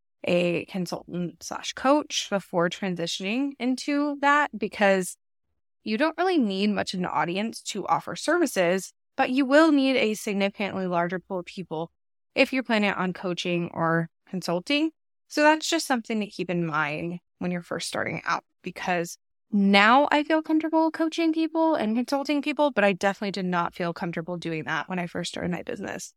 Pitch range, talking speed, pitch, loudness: 180-285 Hz, 170 wpm, 200 Hz, -25 LUFS